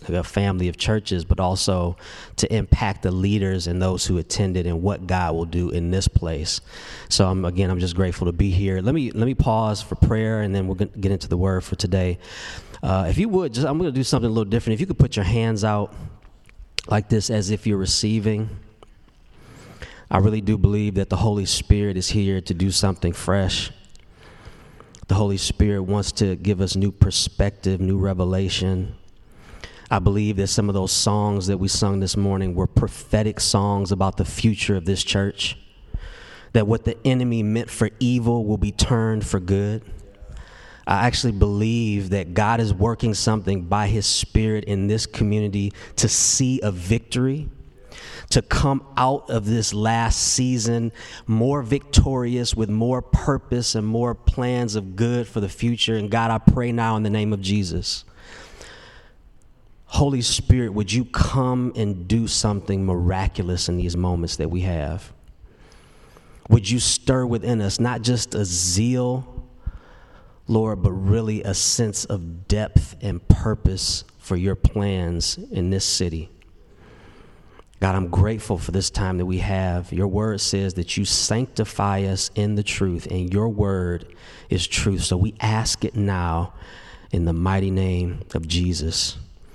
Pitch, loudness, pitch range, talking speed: 100 Hz, -22 LUFS, 95-110 Hz, 170 wpm